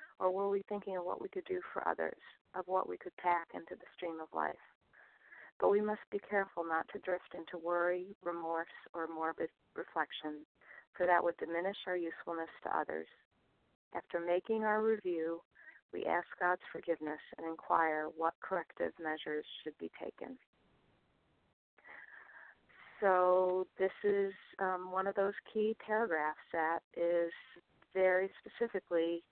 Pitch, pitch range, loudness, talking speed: 180 Hz, 165-195 Hz, -37 LUFS, 145 wpm